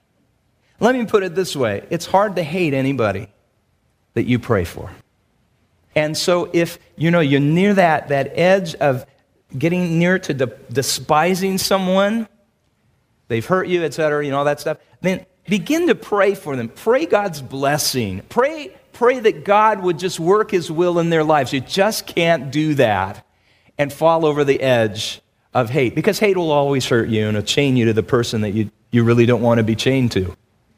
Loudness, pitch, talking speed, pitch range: -18 LUFS, 145 Hz, 190 wpm, 120-180 Hz